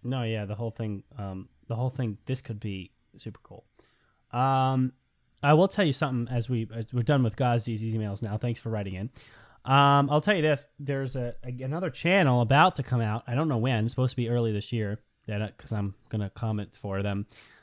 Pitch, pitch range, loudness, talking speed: 120 Hz, 110-135 Hz, -28 LUFS, 220 wpm